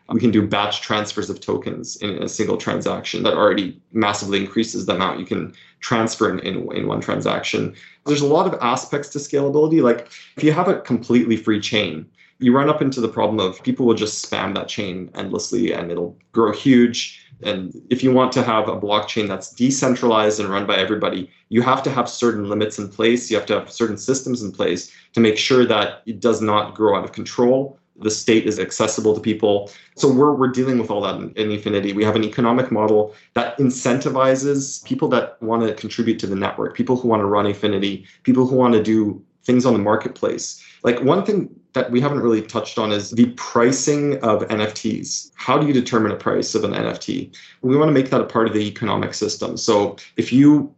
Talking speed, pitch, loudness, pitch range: 215 wpm, 115 Hz, -19 LUFS, 105-130 Hz